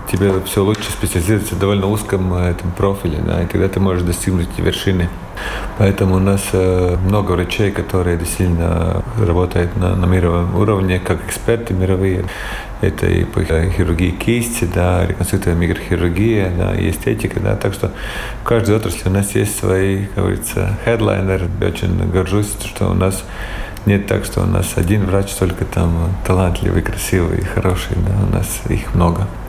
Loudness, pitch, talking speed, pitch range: -17 LUFS, 95 Hz, 160 wpm, 90-105 Hz